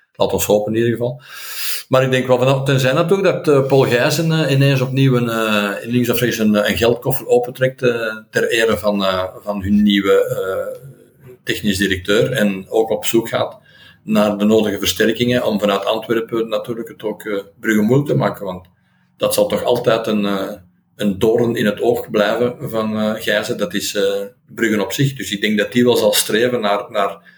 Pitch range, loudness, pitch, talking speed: 105-130 Hz, -17 LUFS, 115 Hz, 200 wpm